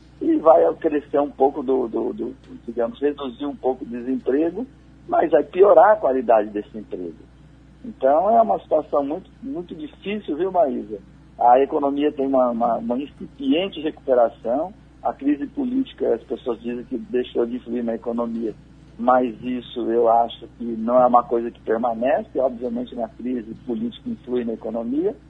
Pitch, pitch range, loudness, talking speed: 125 Hz, 120-155 Hz, -21 LUFS, 160 wpm